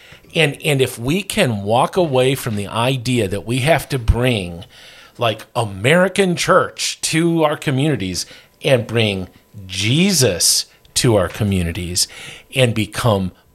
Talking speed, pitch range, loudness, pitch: 130 wpm, 100-150 Hz, -17 LUFS, 125 Hz